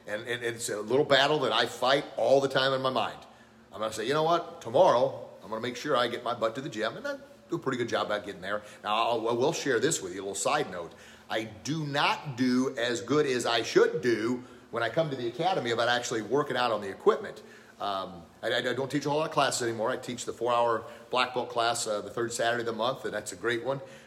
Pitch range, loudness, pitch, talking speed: 115-145 Hz, -29 LUFS, 125 Hz, 270 wpm